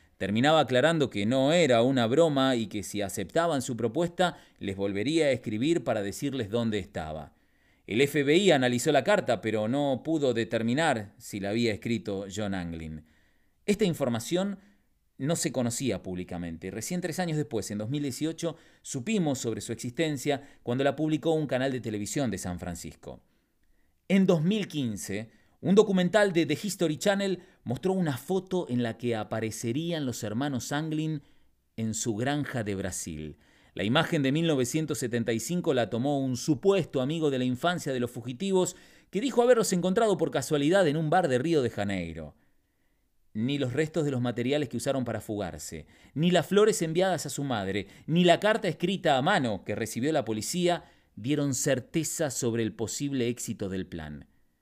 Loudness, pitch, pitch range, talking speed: -28 LUFS, 135 Hz, 110-165 Hz, 165 wpm